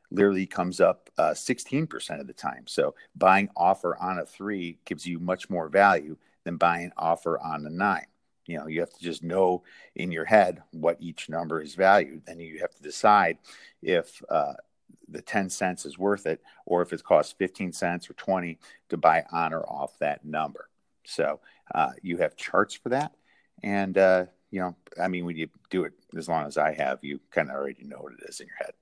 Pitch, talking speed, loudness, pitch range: 90 Hz, 210 wpm, -27 LUFS, 85-95 Hz